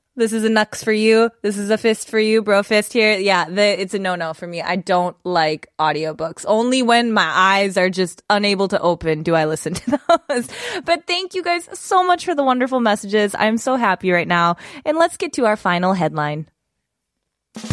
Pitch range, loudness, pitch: 180-235 Hz, -18 LUFS, 210 Hz